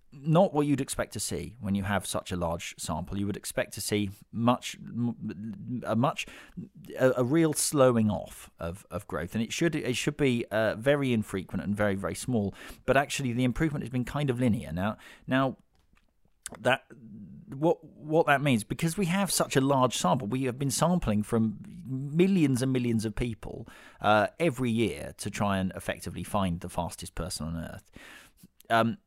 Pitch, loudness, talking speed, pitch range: 120 Hz, -29 LUFS, 185 wpm, 100-140 Hz